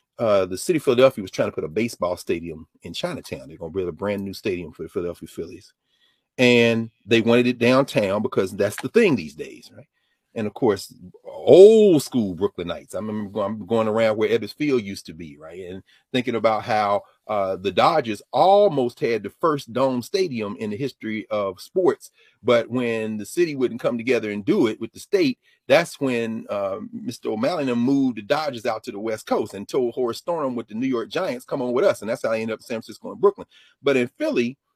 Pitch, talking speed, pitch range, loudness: 120 Hz, 215 wpm, 110-140 Hz, -22 LUFS